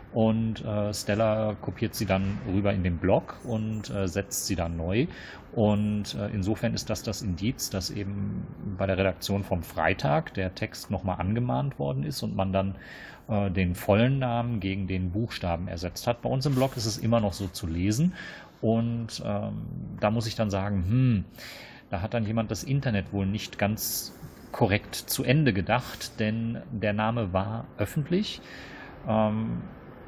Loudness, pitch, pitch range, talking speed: -28 LUFS, 105 Hz, 95-115 Hz, 170 wpm